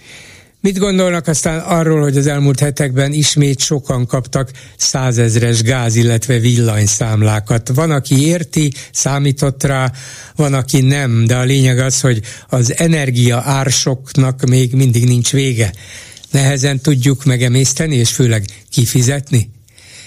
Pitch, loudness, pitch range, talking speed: 130 Hz, -13 LUFS, 120-140 Hz, 125 wpm